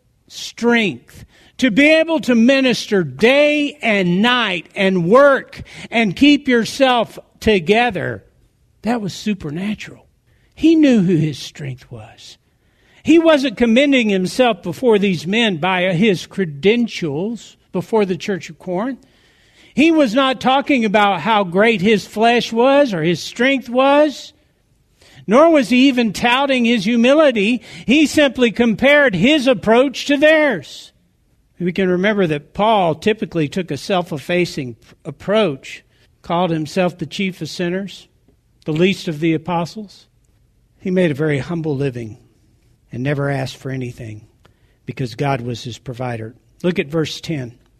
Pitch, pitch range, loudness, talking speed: 195 Hz, 155-240 Hz, -16 LUFS, 135 wpm